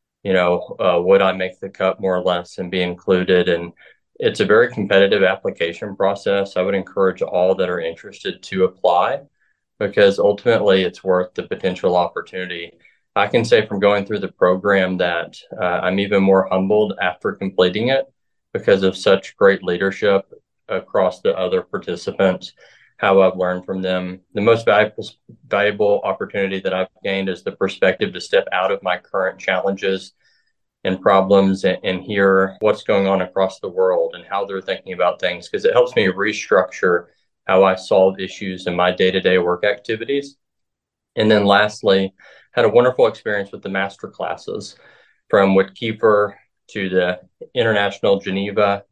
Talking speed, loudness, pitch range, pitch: 165 wpm, -18 LUFS, 95-120 Hz, 95 Hz